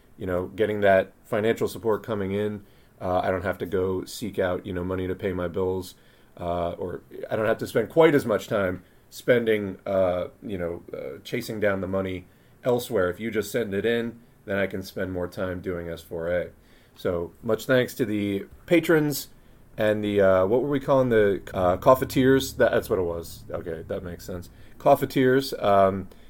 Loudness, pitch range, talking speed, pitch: -25 LUFS, 90-120 Hz, 195 wpm, 100 Hz